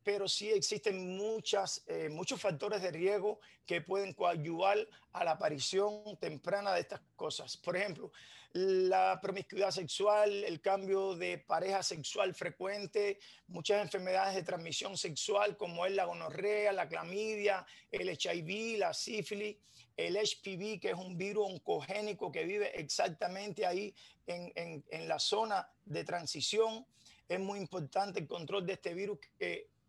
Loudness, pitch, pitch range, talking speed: -36 LUFS, 195 Hz, 180-210 Hz, 145 wpm